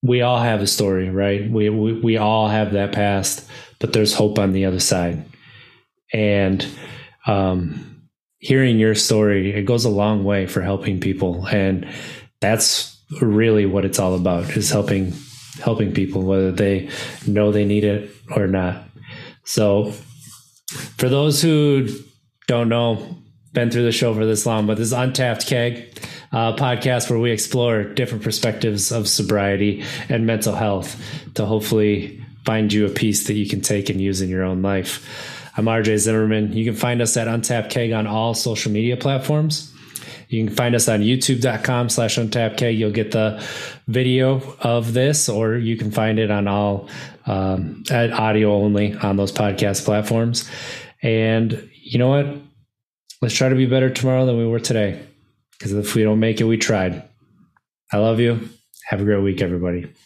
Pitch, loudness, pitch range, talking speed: 110 Hz, -19 LUFS, 105-120 Hz, 170 wpm